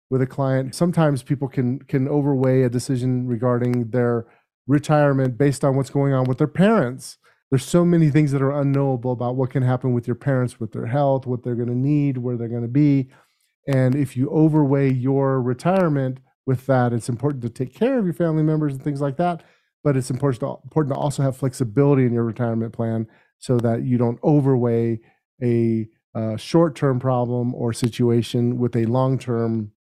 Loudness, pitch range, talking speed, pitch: -21 LUFS, 120-145 Hz, 190 wpm, 130 Hz